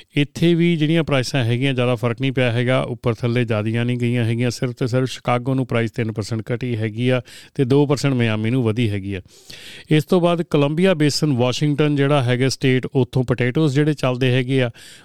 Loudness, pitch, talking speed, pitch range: -19 LUFS, 130 Hz, 185 wpm, 120-145 Hz